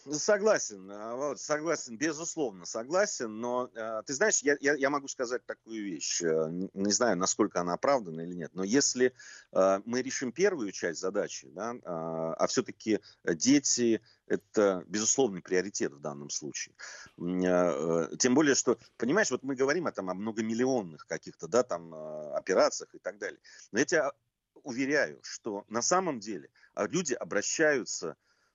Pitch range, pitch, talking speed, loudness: 90-145 Hz, 115 Hz, 135 wpm, -30 LUFS